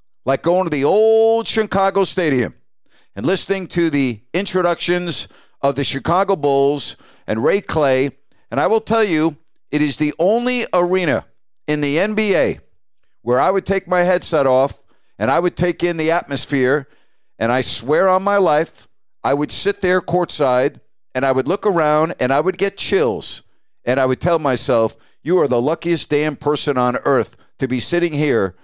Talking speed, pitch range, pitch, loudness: 175 wpm, 135-185 Hz, 160 Hz, -18 LUFS